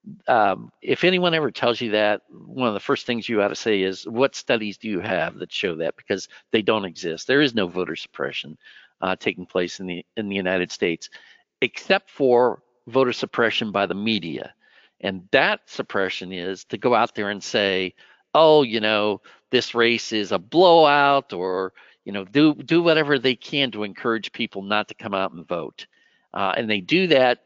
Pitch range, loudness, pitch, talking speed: 95-140 Hz, -22 LUFS, 115 Hz, 195 wpm